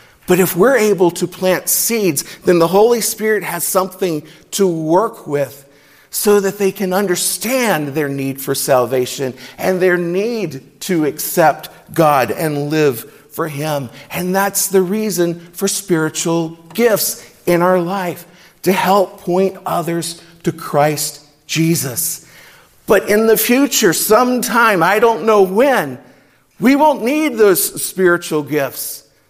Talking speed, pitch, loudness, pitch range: 135 wpm, 180 Hz, -15 LUFS, 150-200 Hz